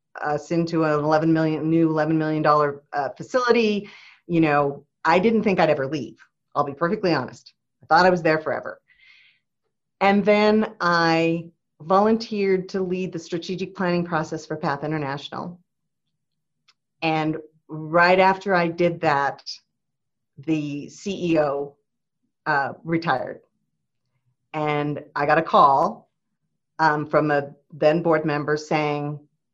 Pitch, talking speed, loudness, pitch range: 160 Hz, 130 wpm, -22 LUFS, 150-180 Hz